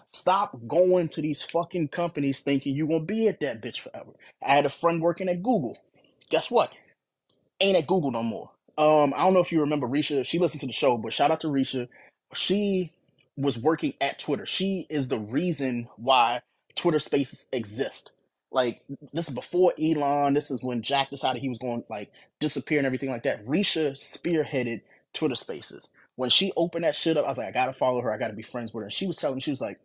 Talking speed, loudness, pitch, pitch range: 220 wpm, -26 LUFS, 145 Hz, 130-170 Hz